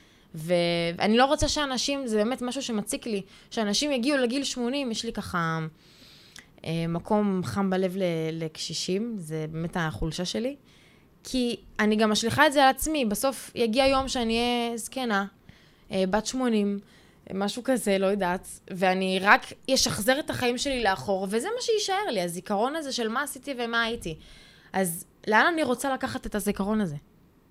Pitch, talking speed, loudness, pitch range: 215 Hz, 155 wpm, -26 LUFS, 185-260 Hz